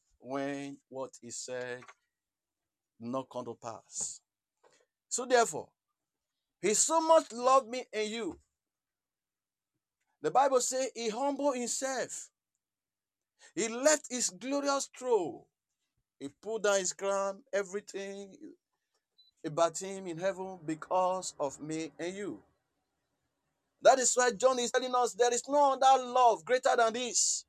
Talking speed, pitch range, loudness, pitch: 125 wpm, 170-260 Hz, -30 LUFS, 225 Hz